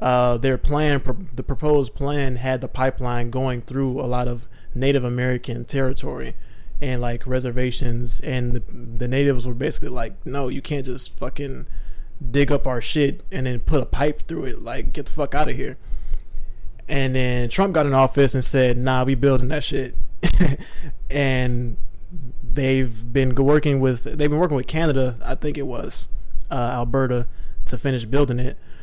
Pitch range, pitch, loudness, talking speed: 120-140 Hz, 130 Hz, -23 LUFS, 175 wpm